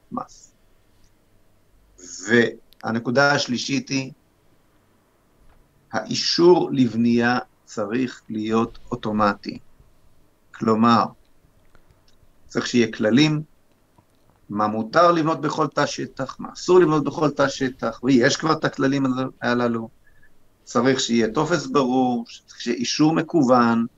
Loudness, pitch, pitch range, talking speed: -21 LUFS, 120 Hz, 110-135 Hz, 90 wpm